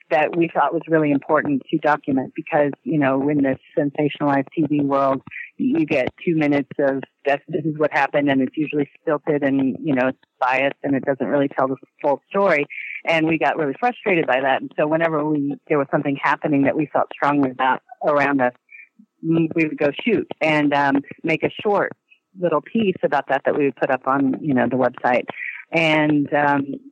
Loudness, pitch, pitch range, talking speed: -20 LUFS, 145 Hz, 140-160 Hz, 200 wpm